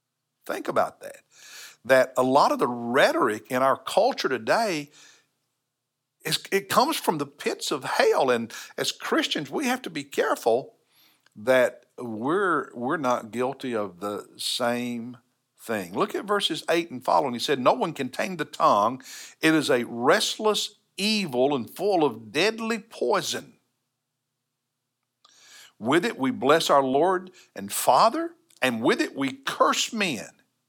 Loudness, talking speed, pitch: -24 LUFS, 150 wpm, 135 Hz